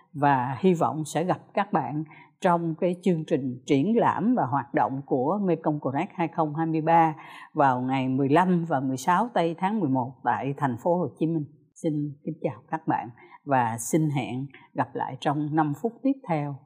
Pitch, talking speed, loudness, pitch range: 155 Hz, 175 wpm, -26 LUFS, 140-170 Hz